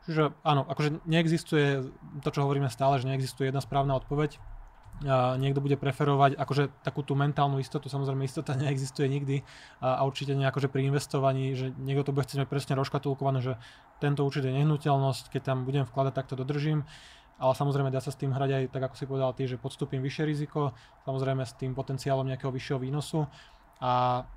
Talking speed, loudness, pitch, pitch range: 185 wpm, -30 LUFS, 135 Hz, 135-145 Hz